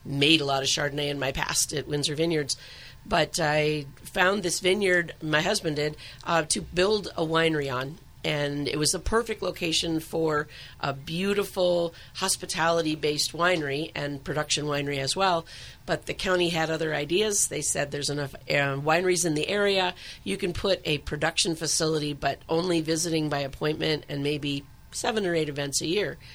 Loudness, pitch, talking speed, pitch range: -26 LUFS, 155 Hz, 170 wpm, 145-175 Hz